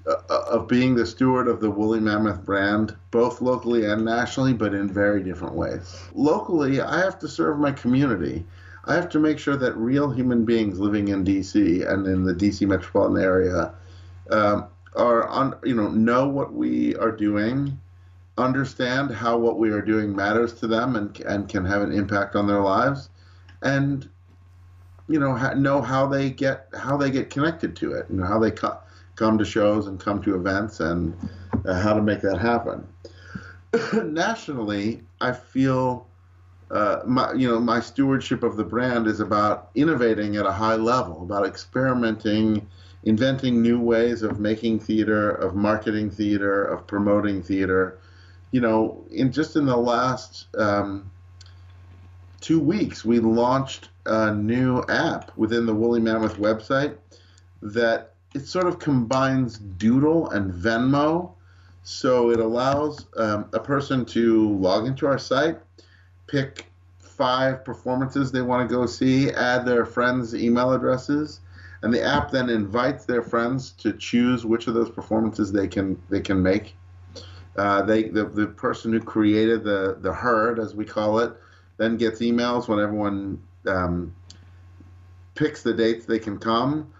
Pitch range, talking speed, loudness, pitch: 95-125 Hz, 160 wpm, -23 LUFS, 110 Hz